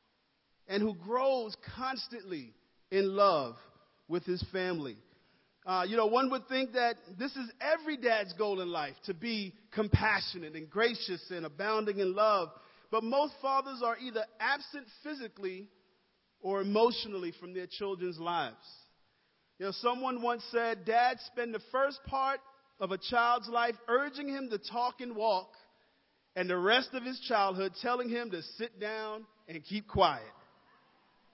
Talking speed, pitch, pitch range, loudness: 150 wpm, 225 Hz, 195-250 Hz, -33 LUFS